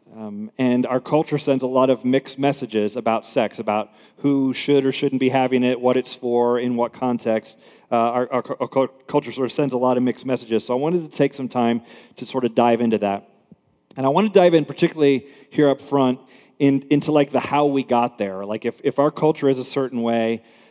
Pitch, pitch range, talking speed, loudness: 130 Hz, 120-140 Hz, 230 wpm, -21 LUFS